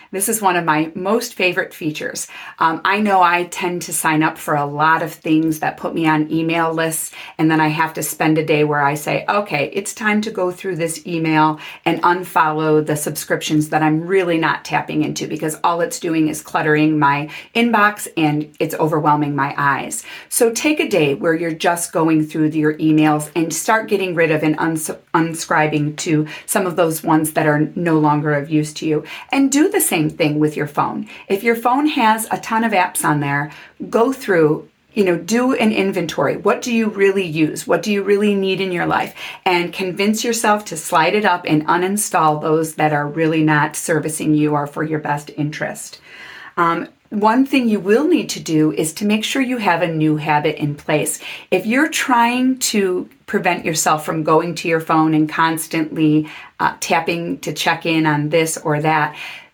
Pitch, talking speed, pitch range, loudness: 165 Hz, 205 wpm, 155-195 Hz, -17 LUFS